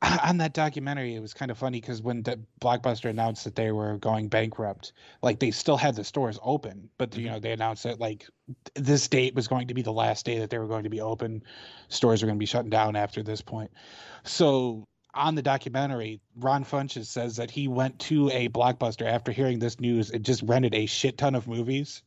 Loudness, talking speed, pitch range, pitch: -28 LUFS, 225 wpm, 110-130 Hz, 120 Hz